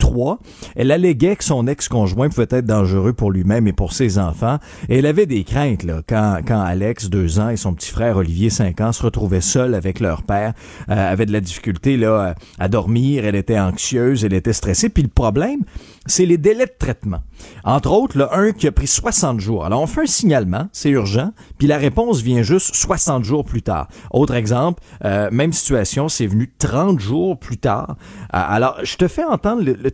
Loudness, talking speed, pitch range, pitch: -17 LUFS, 210 wpm, 100-150 Hz, 120 Hz